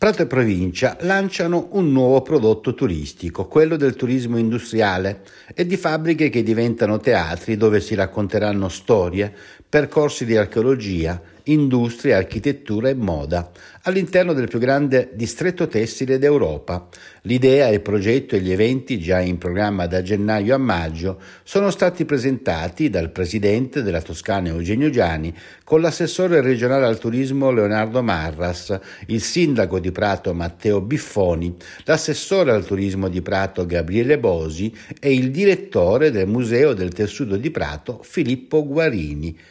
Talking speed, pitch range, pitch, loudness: 135 wpm, 95-145 Hz, 115 Hz, -19 LUFS